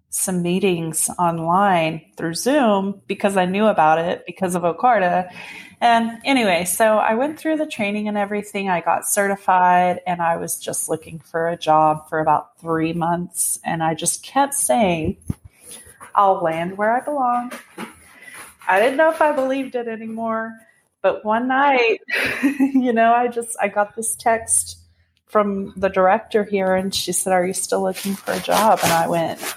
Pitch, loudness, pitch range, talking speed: 195 Hz, -19 LUFS, 170-230 Hz, 170 wpm